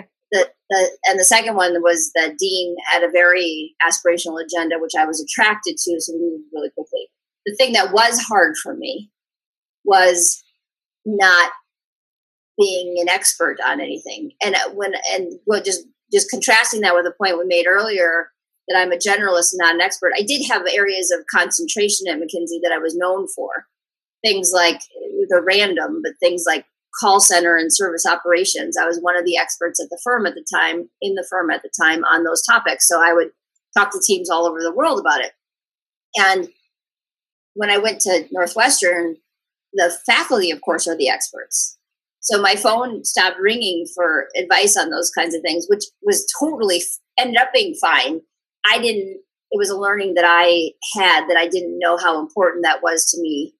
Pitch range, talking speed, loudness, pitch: 170-210 Hz, 190 wpm, -17 LUFS, 180 Hz